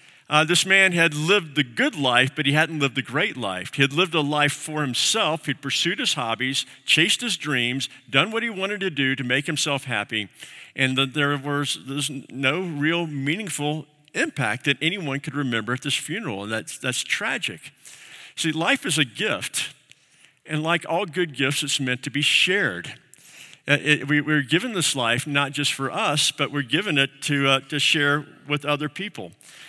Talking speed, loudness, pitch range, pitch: 195 wpm, -22 LUFS, 135-155 Hz, 145 Hz